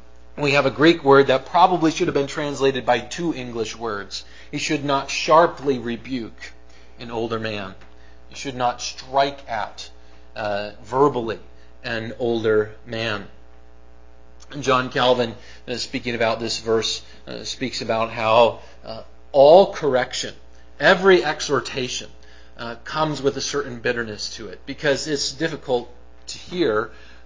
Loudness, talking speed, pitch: -21 LUFS, 140 wpm, 115 Hz